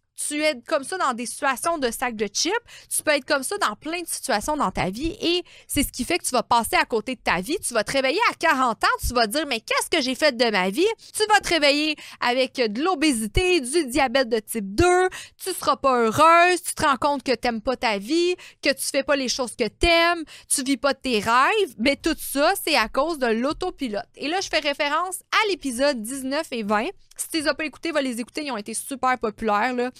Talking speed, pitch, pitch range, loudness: 260 wpm, 280 Hz, 245-335 Hz, -22 LUFS